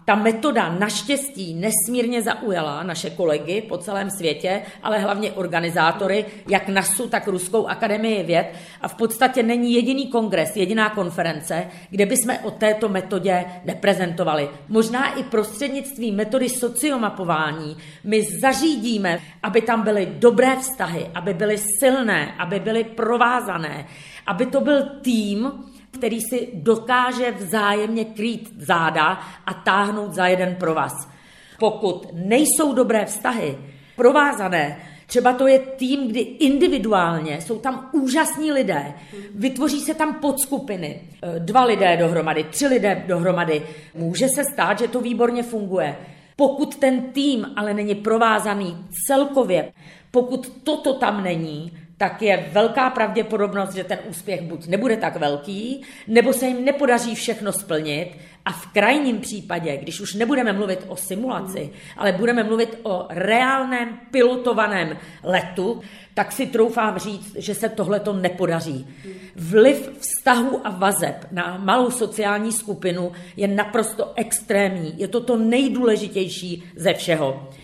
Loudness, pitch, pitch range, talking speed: -21 LUFS, 210 Hz, 180-245 Hz, 130 wpm